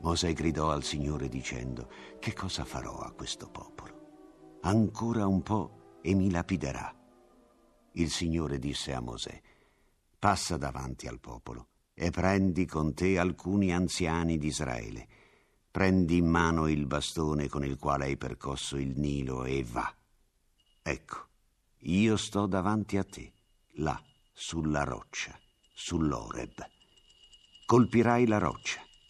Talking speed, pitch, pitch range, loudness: 125 wpm, 80 Hz, 70-95 Hz, -31 LUFS